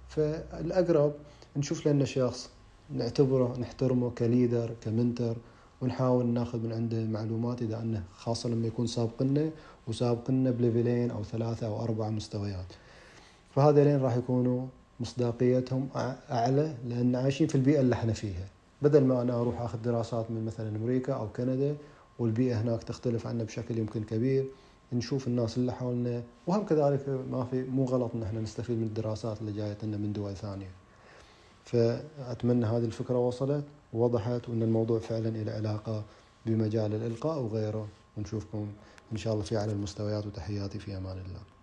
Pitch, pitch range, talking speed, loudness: 120 Hz, 110-130 Hz, 145 wpm, -31 LUFS